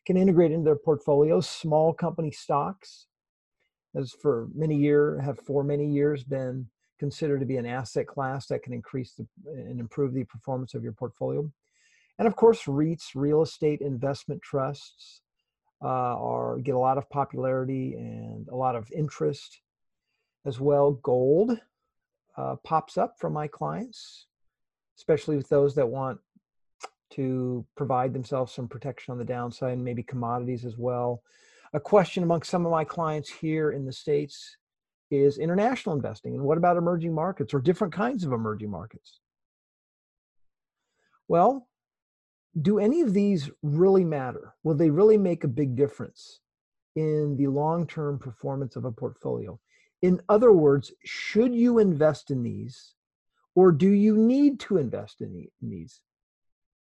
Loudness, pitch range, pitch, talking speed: -26 LUFS, 130-165 Hz, 145 Hz, 150 wpm